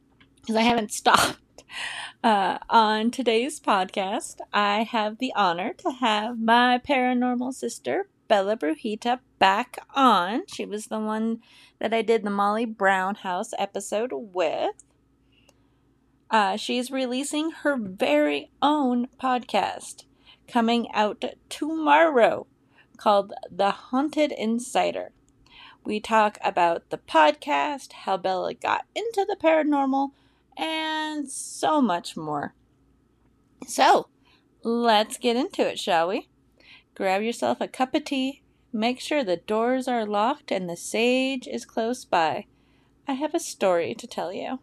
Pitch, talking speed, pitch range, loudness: 235 Hz, 125 wpm, 210-280 Hz, -24 LUFS